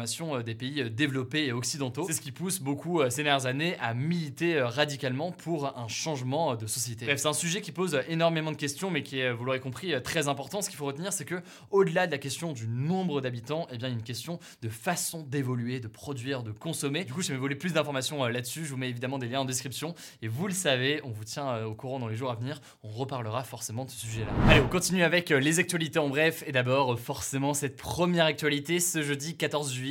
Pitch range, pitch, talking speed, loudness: 125-160 Hz, 140 Hz, 265 wpm, -30 LUFS